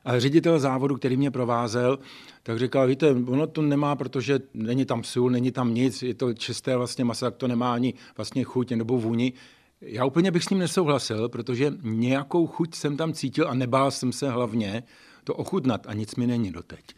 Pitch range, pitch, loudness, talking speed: 120-140 Hz, 125 Hz, -25 LUFS, 200 wpm